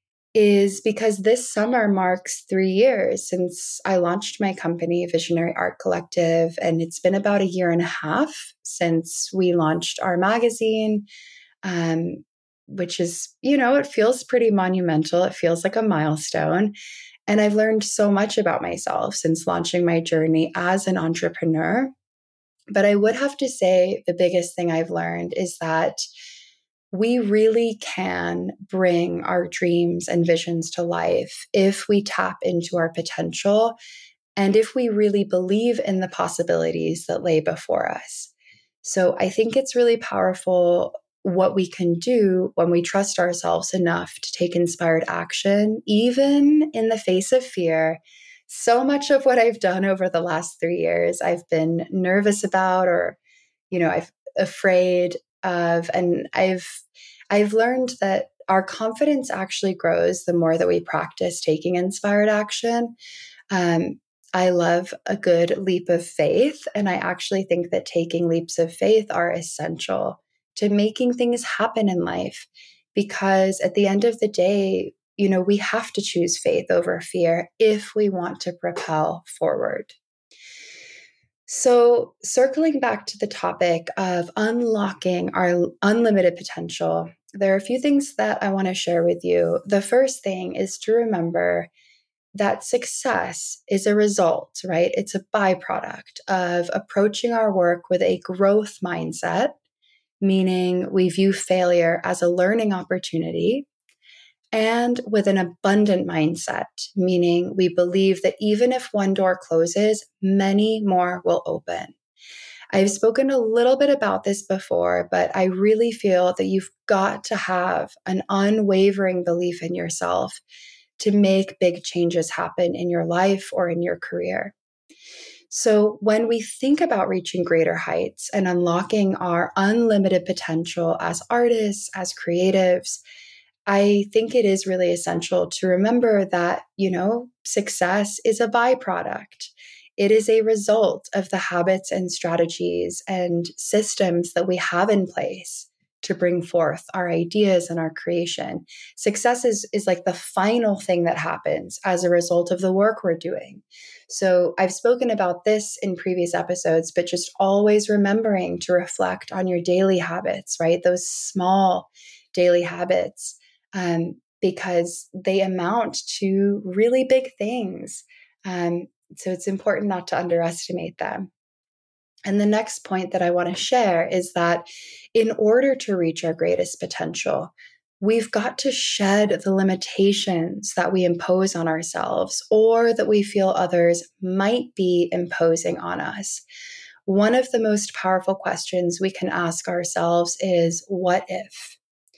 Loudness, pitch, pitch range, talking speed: -21 LUFS, 190 Hz, 175-220 Hz, 150 wpm